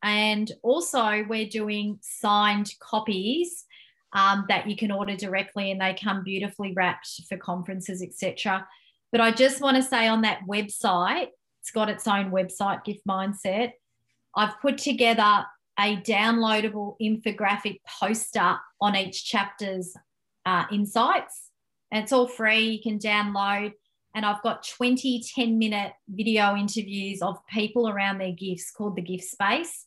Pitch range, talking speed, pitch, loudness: 195-220 Hz, 145 wpm, 205 Hz, -25 LUFS